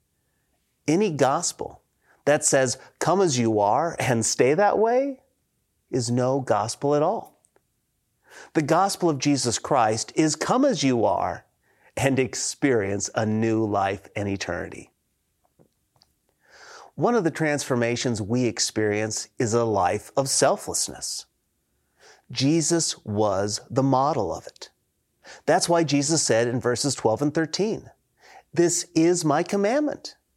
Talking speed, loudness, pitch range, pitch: 125 wpm, -23 LUFS, 110-160 Hz, 130 Hz